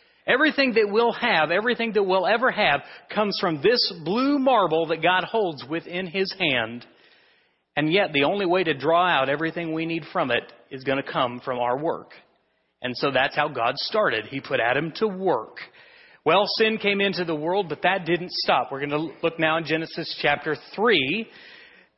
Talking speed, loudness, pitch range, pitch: 190 wpm, -23 LUFS, 150-210 Hz, 170 Hz